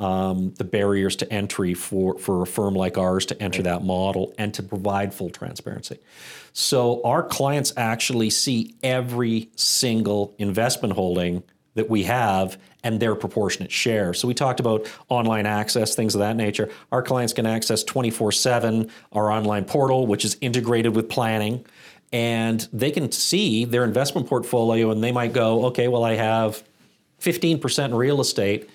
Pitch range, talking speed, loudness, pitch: 100-120 Hz, 165 wpm, -22 LUFS, 110 Hz